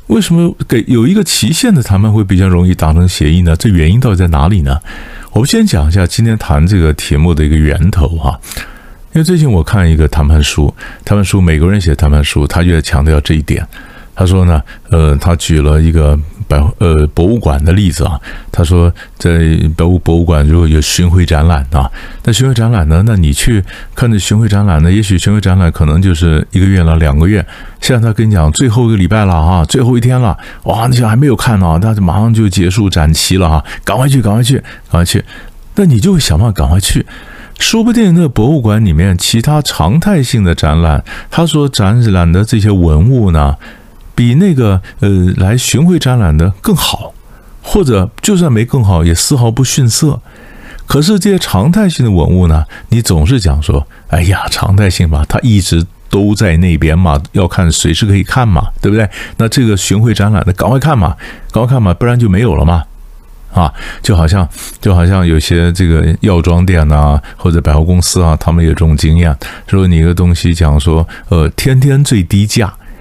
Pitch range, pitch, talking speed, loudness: 80-115 Hz, 95 Hz, 300 characters per minute, -10 LUFS